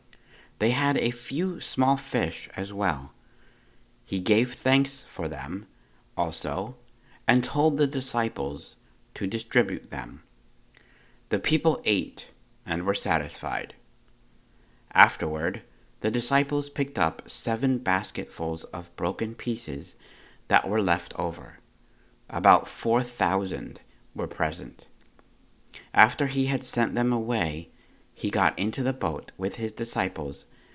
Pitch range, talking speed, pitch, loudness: 95-130 Hz, 115 wpm, 115 Hz, -26 LUFS